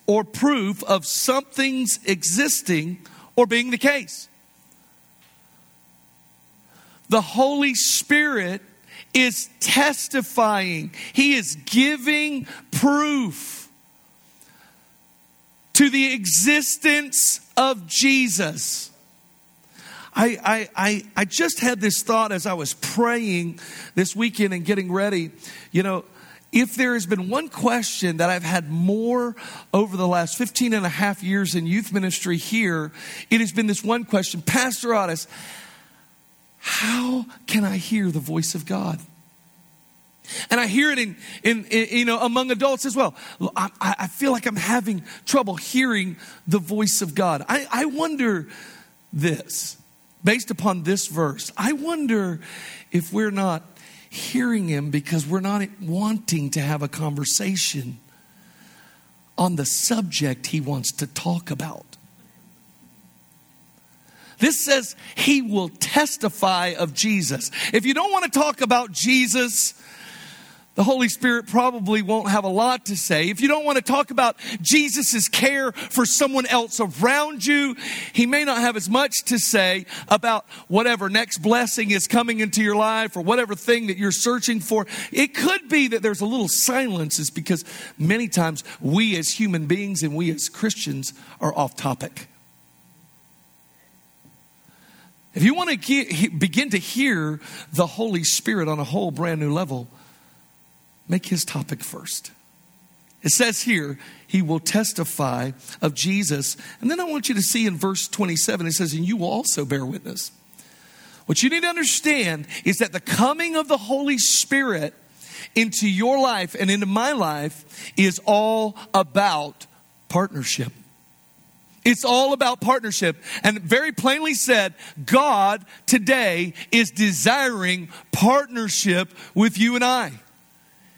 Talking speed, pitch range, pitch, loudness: 140 wpm, 170-245 Hz, 205 Hz, -21 LUFS